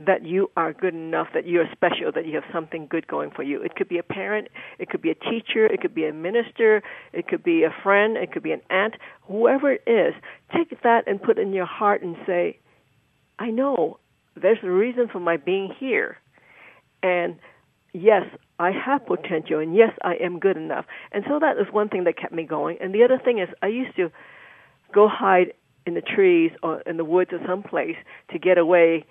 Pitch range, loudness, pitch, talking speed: 175-260 Hz, -22 LUFS, 195 Hz, 220 wpm